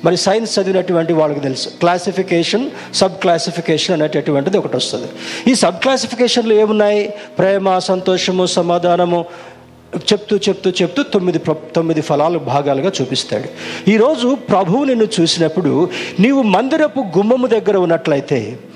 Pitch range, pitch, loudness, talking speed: 165-210 Hz, 185 Hz, -15 LUFS, 115 wpm